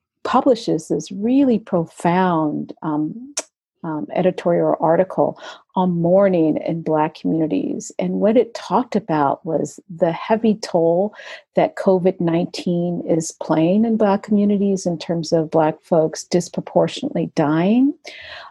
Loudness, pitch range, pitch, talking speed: -19 LUFS, 160-210 Hz, 180 Hz, 120 wpm